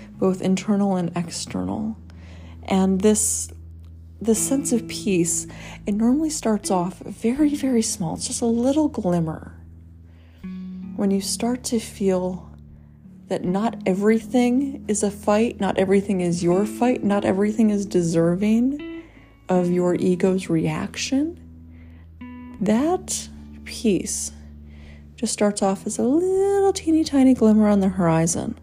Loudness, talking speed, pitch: -21 LUFS, 125 wpm, 190 Hz